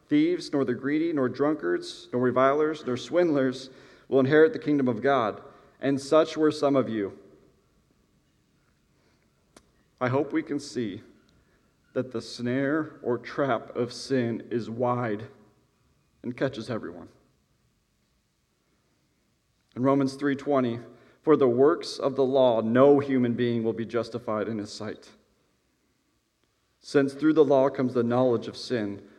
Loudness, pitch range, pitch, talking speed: -26 LUFS, 120-140 Hz, 130 Hz, 135 wpm